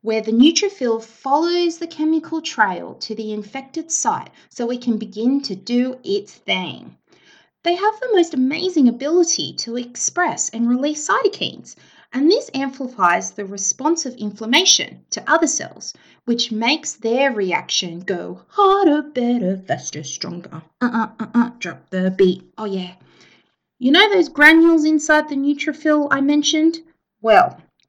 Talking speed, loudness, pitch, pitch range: 150 wpm, -18 LUFS, 270 Hz, 220-320 Hz